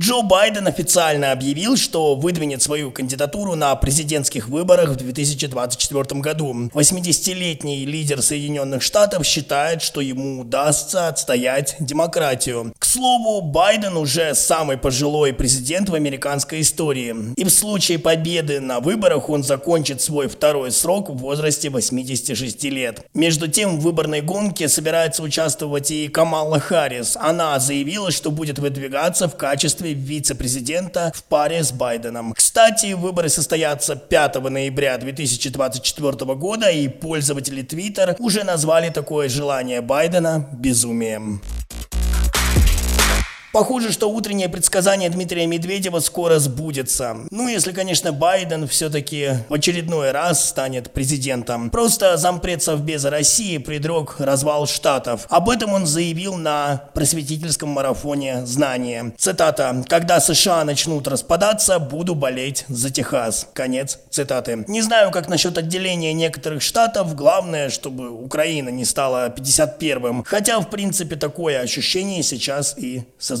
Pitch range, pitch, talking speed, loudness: 135-170 Hz, 150 Hz, 125 wpm, -19 LUFS